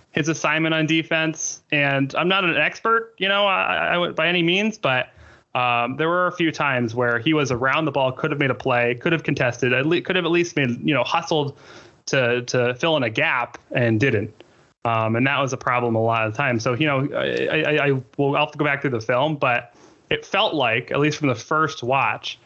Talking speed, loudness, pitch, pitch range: 245 wpm, -21 LUFS, 145 Hz, 125-160 Hz